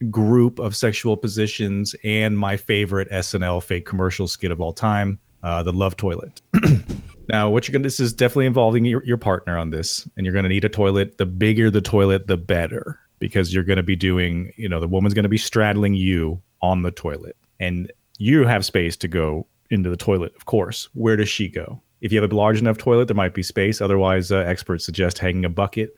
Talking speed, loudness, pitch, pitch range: 220 wpm, -21 LUFS, 100 Hz, 90-110 Hz